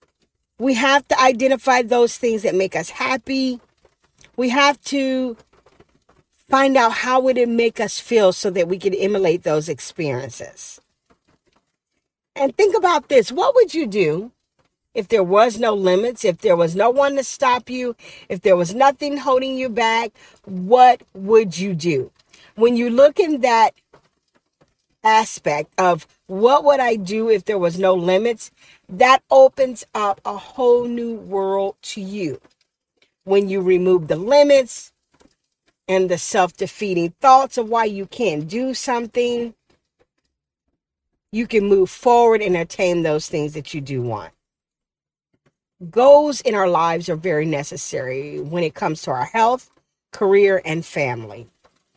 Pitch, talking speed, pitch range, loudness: 220 Hz, 150 wpm, 185-255 Hz, -18 LUFS